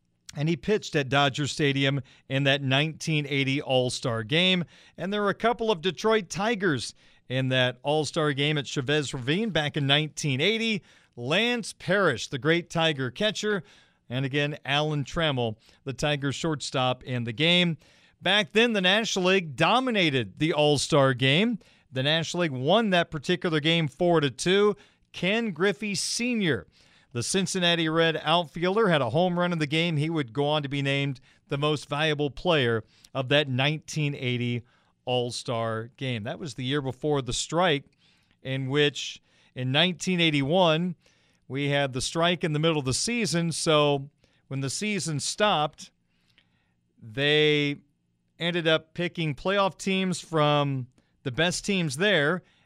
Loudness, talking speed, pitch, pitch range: -25 LUFS, 155 wpm, 150 Hz, 135-175 Hz